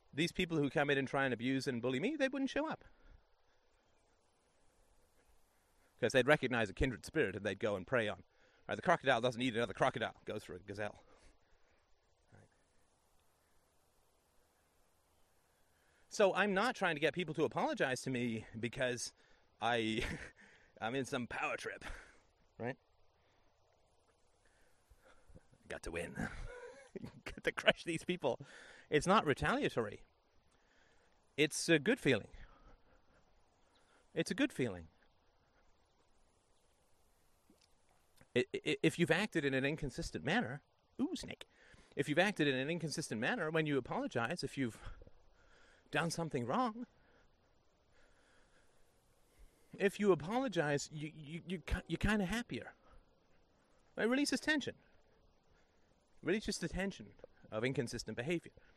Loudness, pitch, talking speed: -37 LUFS, 135 Hz, 125 wpm